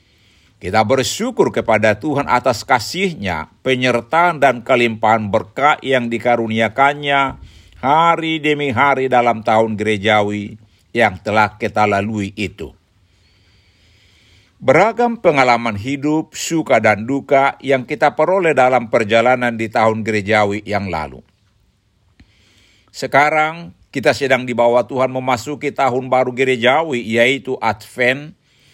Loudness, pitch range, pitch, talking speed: -16 LUFS, 105-135 Hz, 120 Hz, 105 wpm